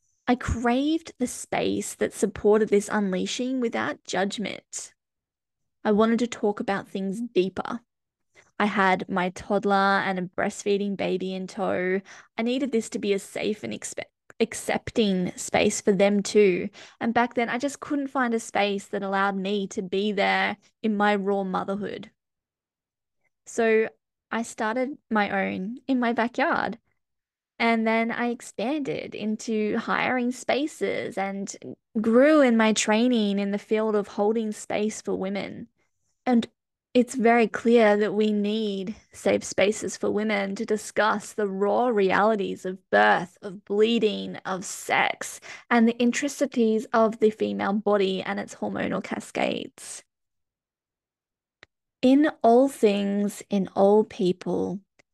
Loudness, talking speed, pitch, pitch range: -25 LUFS, 140 wpm, 215 Hz, 200-235 Hz